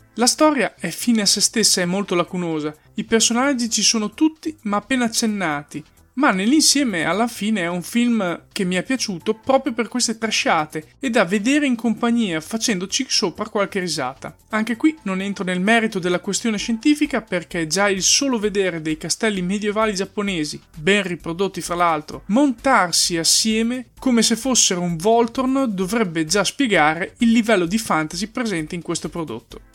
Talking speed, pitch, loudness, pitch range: 165 wpm, 210 Hz, -19 LUFS, 180-235 Hz